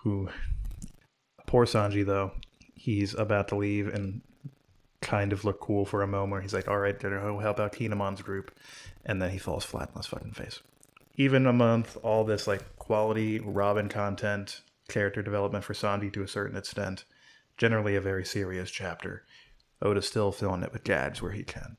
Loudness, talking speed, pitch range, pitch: -30 LUFS, 180 wpm, 100-105 Hz, 100 Hz